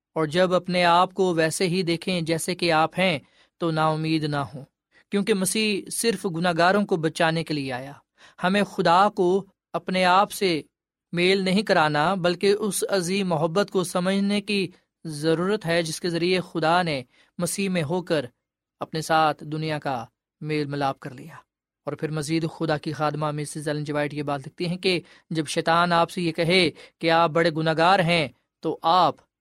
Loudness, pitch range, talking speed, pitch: -23 LUFS, 155-185 Hz, 180 wpm, 170 Hz